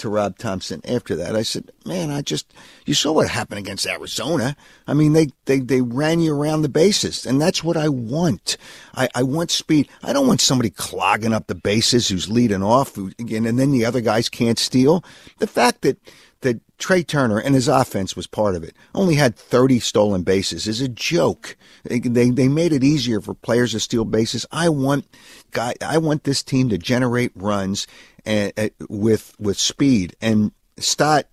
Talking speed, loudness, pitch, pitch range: 200 wpm, -19 LUFS, 120 Hz, 105-140 Hz